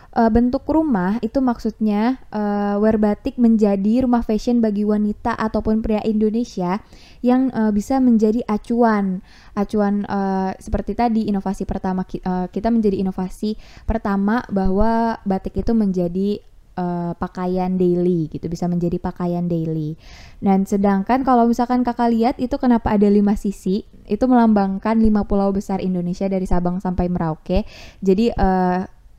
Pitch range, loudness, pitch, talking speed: 190-225 Hz, -19 LUFS, 205 Hz, 135 wpm